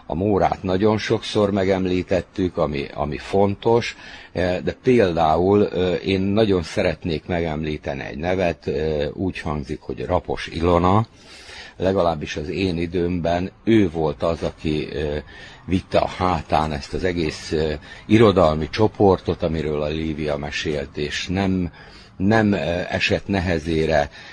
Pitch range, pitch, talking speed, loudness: 80-95 Hz, 90 Hz, 115 wpm, -21 LUFS